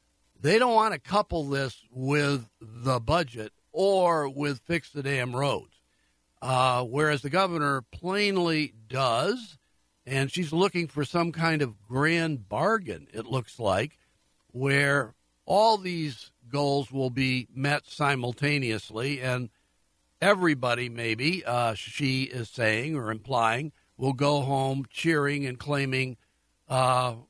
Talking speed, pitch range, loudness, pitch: 125 wpm, 125-155 Hz, -27 LUFS, 140 Hz